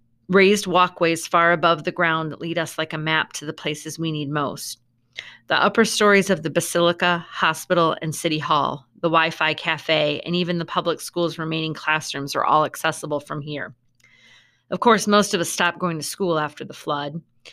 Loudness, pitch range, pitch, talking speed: -21 LUFS, 155-175 Hz, 160 Hz, 190 wpm